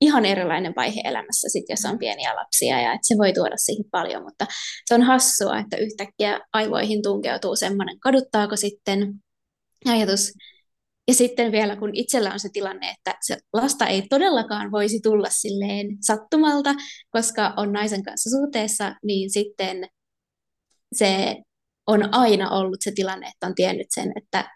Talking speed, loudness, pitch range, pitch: 155 wpm, -22 LUFS, 200-230 Hz, 210 Hz